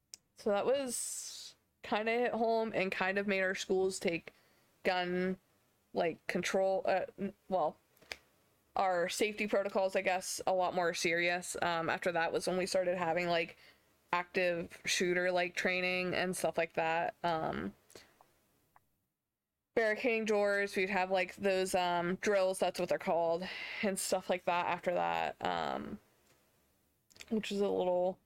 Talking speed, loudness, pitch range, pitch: 145 wpm, -34 LUFS, 175-195 Hz, 185 Hz